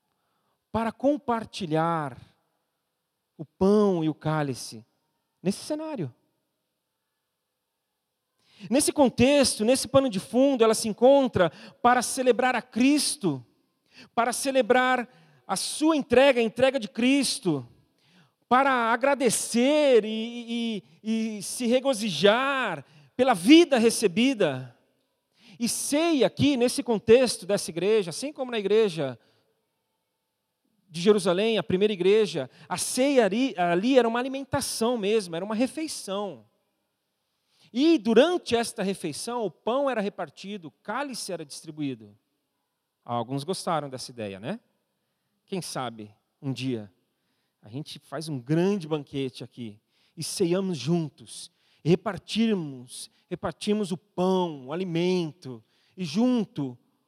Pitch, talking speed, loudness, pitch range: 205 Hz, 110 wpm, -25 LUFS, 160-245 Hz